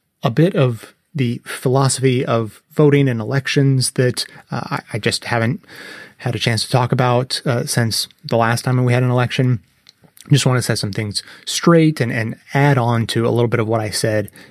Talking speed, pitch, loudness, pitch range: 200 wpm, 125 Hz, -17 LUFS, 115-135 Hz